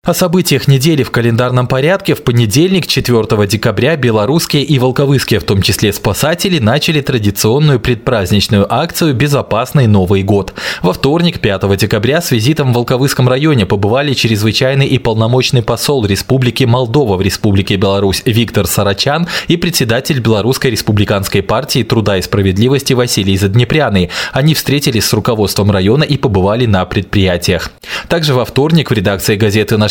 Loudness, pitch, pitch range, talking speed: -11 LUFS, 120 Hz, 105-140 Hz, 140 wpm